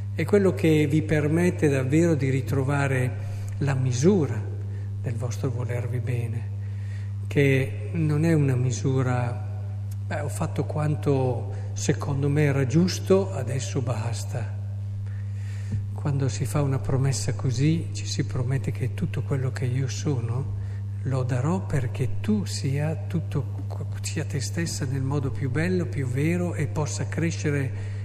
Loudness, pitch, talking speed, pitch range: -26 LUFS, 115 Hz, 135 wpm, 100-135 Hz